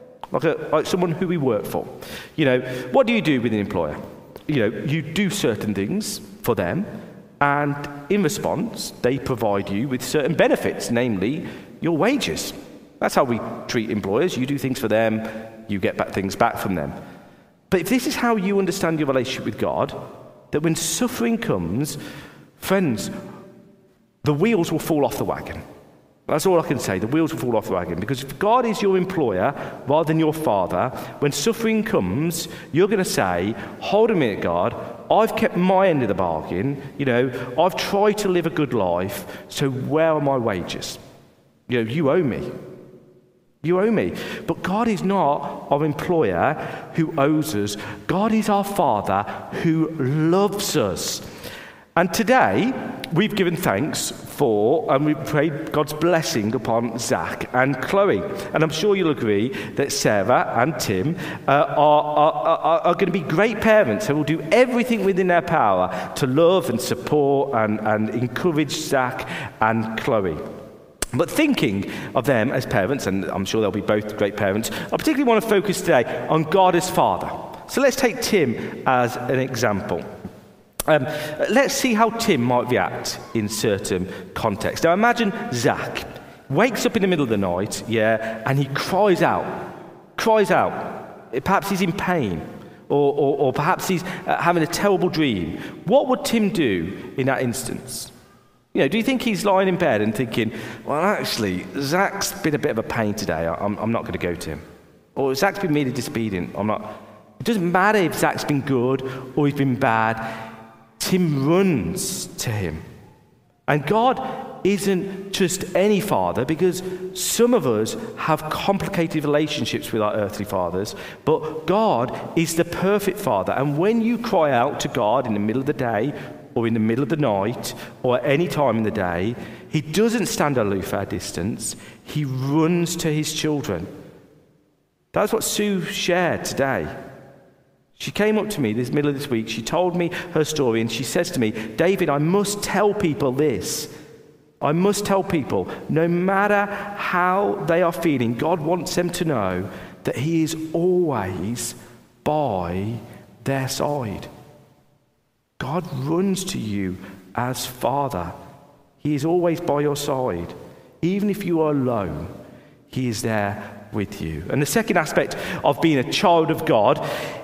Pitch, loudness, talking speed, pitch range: 155 Hz, -21 LUFS, 175 wpm, 125-190 Hz